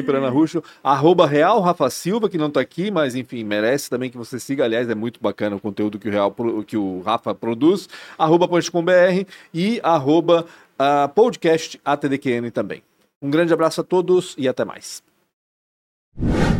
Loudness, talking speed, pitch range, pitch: -19 LUFS, 165 wpm, 120-170 Hz, 145 Hz